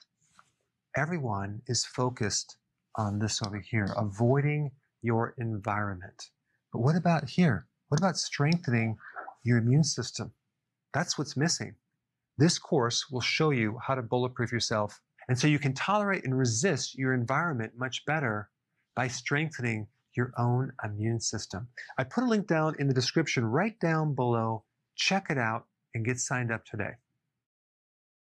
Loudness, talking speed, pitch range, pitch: -30 LUFS, 145 wpm, 115-150 Hz, 125 Hz